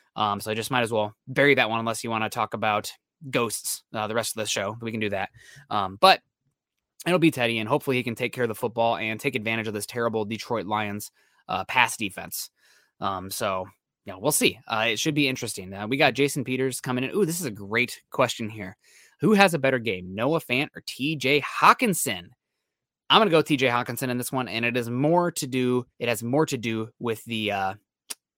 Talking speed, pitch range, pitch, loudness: 230 wpm, 110-135 Hz, 120 Hz, -25 LUFS